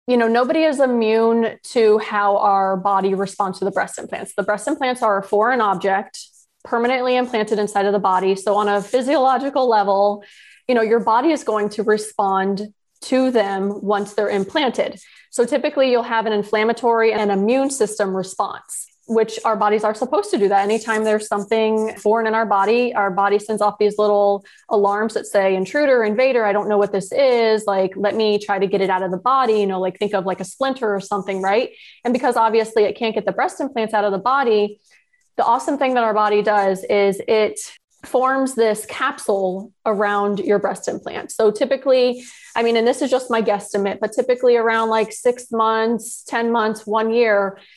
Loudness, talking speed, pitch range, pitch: -19 LUFS, 200 wpm, 205-245 Hz, 215 Hz